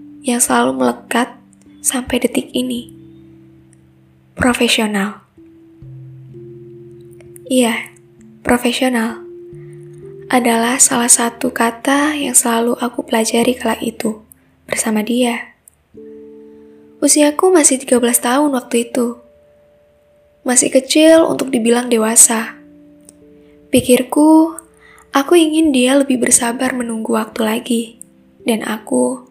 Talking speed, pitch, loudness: 90 wpm, 230 Hz, -14 LUFS